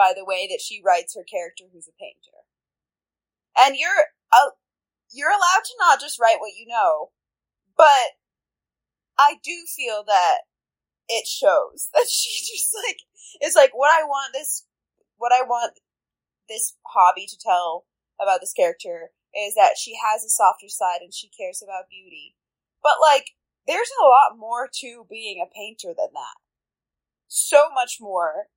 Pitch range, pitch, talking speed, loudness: 210-325 Hz, 265 Hz, 160 wpm, -20 LUFS